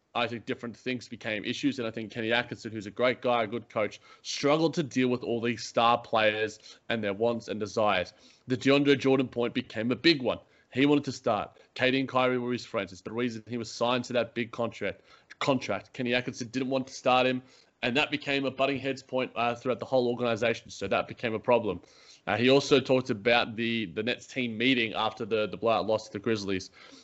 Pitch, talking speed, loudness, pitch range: 120 Hz, 225 wpm, -29 LUFS, 115-130 Hz